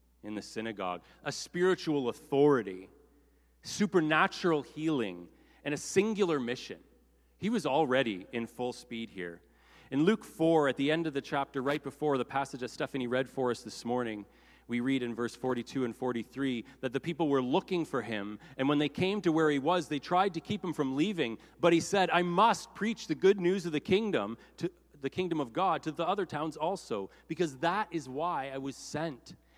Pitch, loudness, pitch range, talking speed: 145 Hz, -32 LUFS, 120-170 Hz, 195 wpm